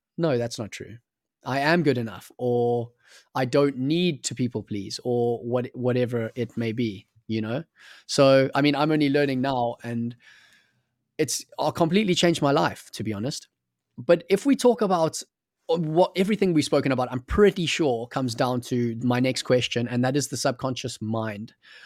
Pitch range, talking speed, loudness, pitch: 120-155 Hz, 180 wpm, -24 LUFS, 130 Hz